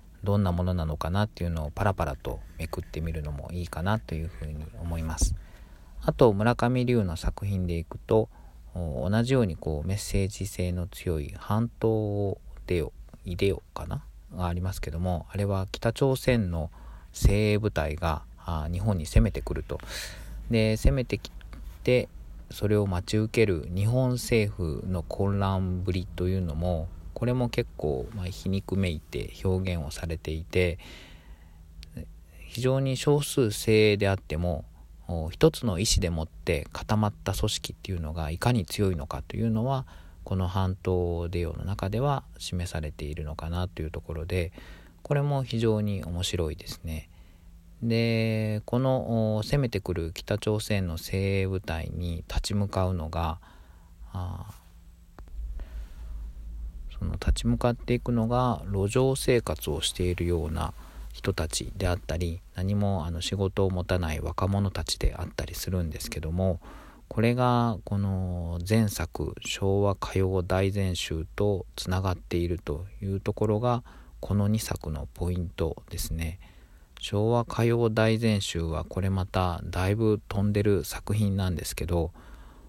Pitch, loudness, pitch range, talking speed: 90 Hz, -29 LUFS, 80-105 Hz, 280 characters per minute